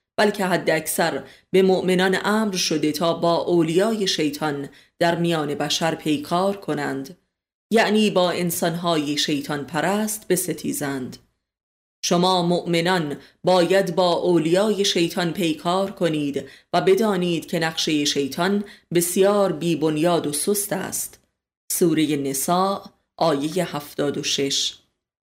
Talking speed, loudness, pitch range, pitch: 105 wpm, -21 LUFS, 150-185 Hz, 170 Hz